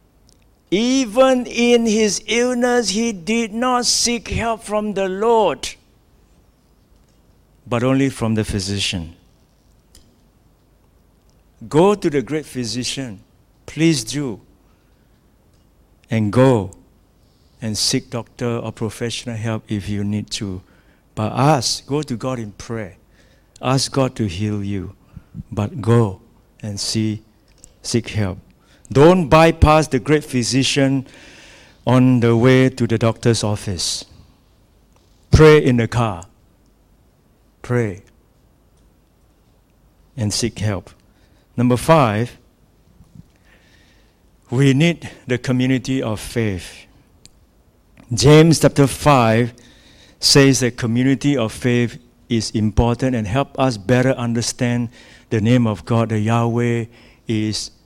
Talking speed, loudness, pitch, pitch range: 110 wpm, -18 LUFS, 120 Hz, 105-135 Hz